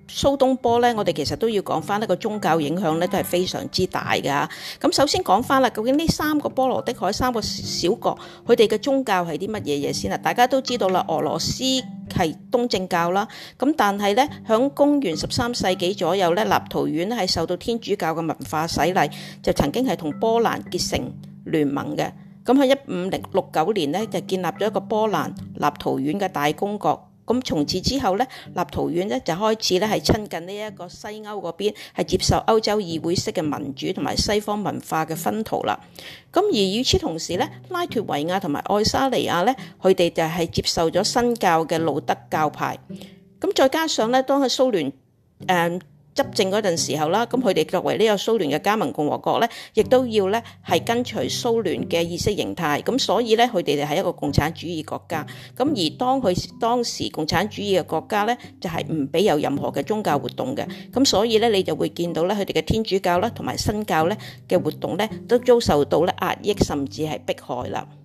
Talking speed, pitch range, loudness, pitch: 300 characters per minute, 170-240 Hz, -22 LUFS, 195 Hz